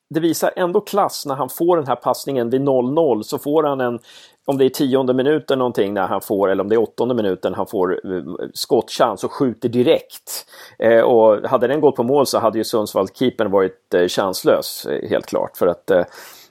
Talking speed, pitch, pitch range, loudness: 205 wpm, 145 Hz, 130-210 Hz, -18 LUFS